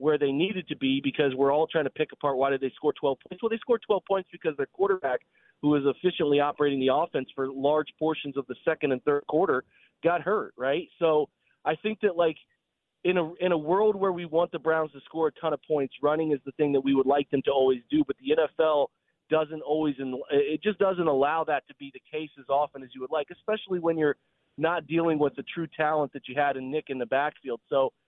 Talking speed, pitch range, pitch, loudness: 250 wpm, 140-170 Hz, 155 Hz, -27 LUFS